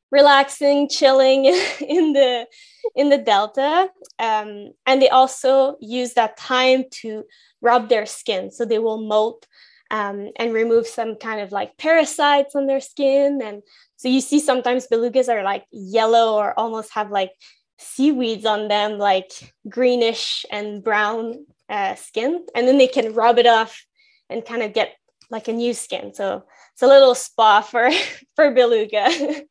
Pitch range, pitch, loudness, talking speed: 220-275 Hz, 240 Hz, -18 LUFS, 160 wpm